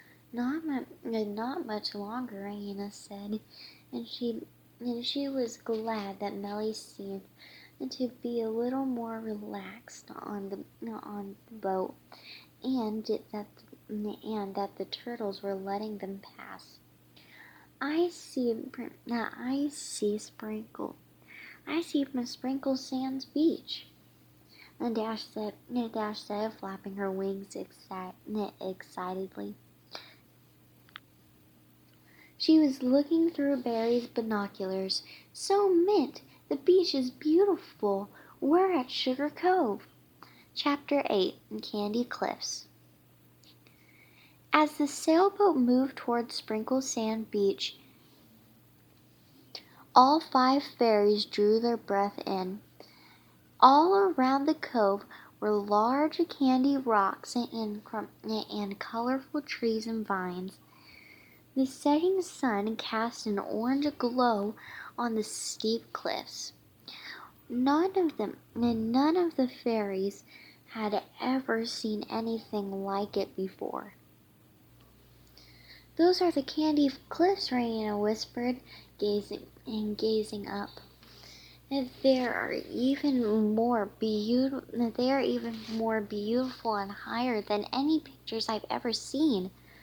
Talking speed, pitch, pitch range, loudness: 105 wpm, 225 Hz, 205-265 Hz, -30 LUFS